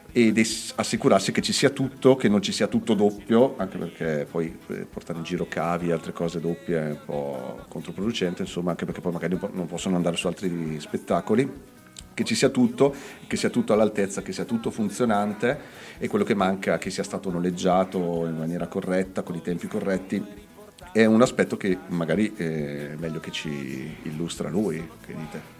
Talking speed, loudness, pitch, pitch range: 185 wpm, -25 LUFS, 90 Hz, 85-110 Hz